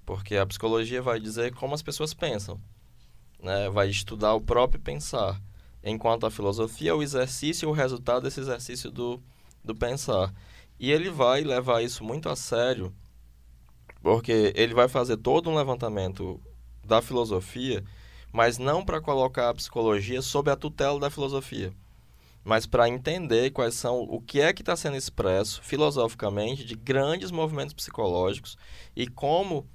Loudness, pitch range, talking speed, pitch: -27 LUFS, 100-130 Hz, 155 wpm, 115 Hz